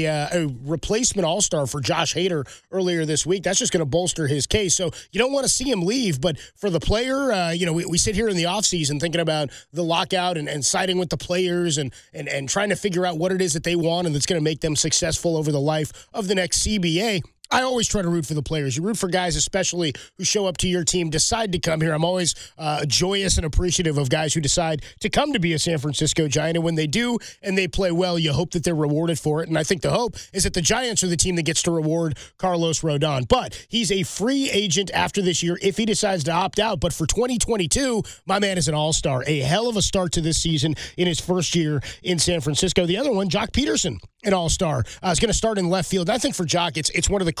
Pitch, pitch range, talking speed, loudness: 175 Hz, 155-190 Hz, 270 wpm, -22 LUFS